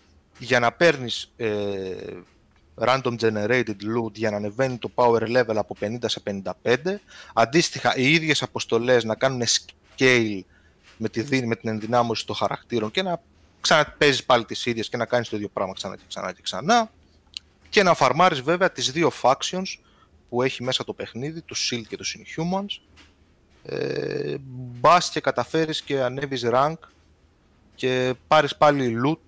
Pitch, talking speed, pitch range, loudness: 125 Hz, 155 wpm, 110-150 Hz, -23 LUFS